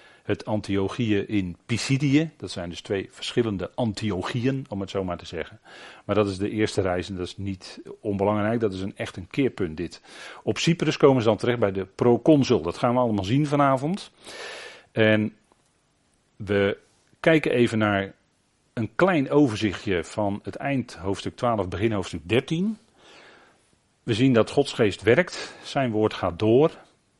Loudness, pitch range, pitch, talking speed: -24 LUFS, 100-130 Hz, 110 Hz, 165 wpm